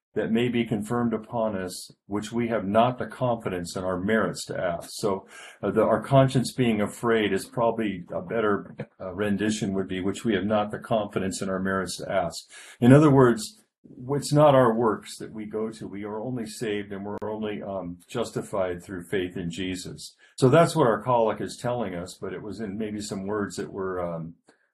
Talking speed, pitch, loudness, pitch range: 205 wpm, 105 Hz, -26 LUFS, 95-115 Hz